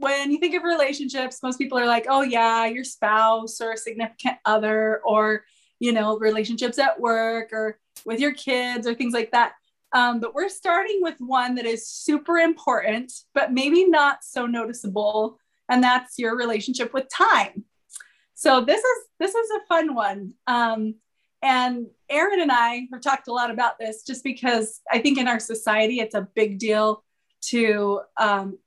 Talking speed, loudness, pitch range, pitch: 175 wpm, -22 LUFS, 220-270 Hz, 240 Hz